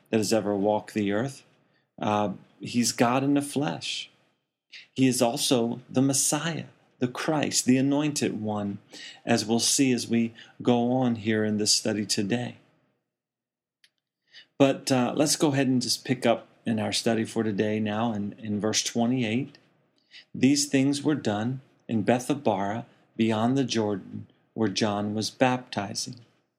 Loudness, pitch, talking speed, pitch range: -26 LUFS, 120 Hz, 150 wpm, 110-135 Hz